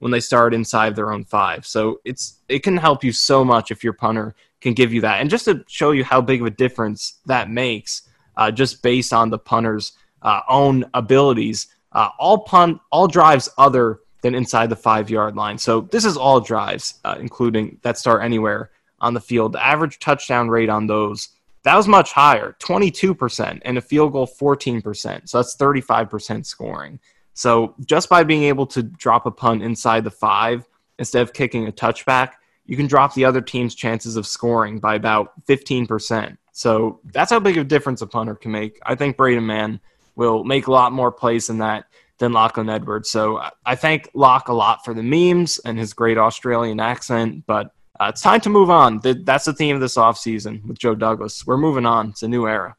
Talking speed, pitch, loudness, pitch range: 210 wpm, 120 Hz, -18 LUFS, 110-135 Hz